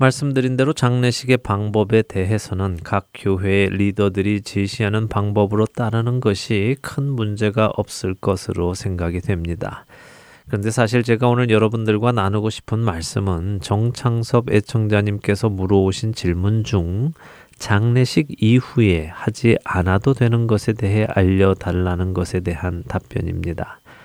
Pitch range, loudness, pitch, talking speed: 95-115 Hz, -19 LUFS, 105 Hz, 305 characters per minute